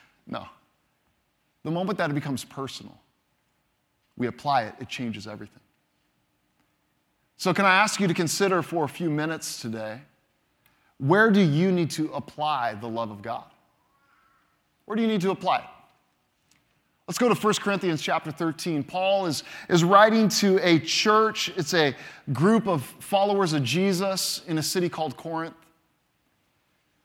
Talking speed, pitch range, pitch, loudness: 150 wpm, 140-190 Hz, 165 Hz, -24 LUFS